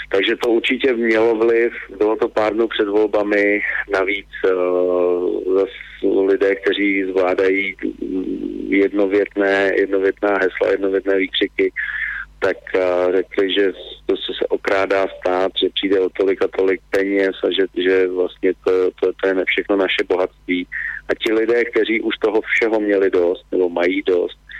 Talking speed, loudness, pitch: 150 wpm, -18 LUFS, 110 Hz